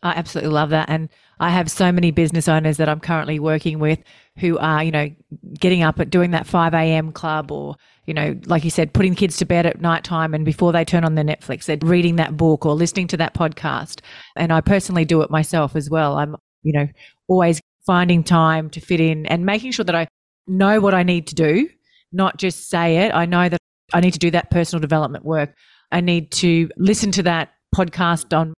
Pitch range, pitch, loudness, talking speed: 155-175 Hz, 165 Hz, -18 LUFS, 225 wpm